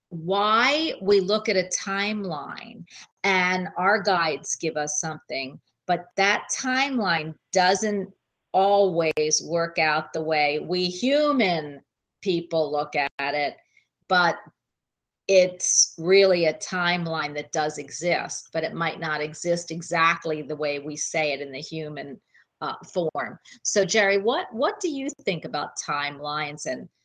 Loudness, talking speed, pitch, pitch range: -24 LUFS, 135 wpm, 170 Hz, 155-195 Hz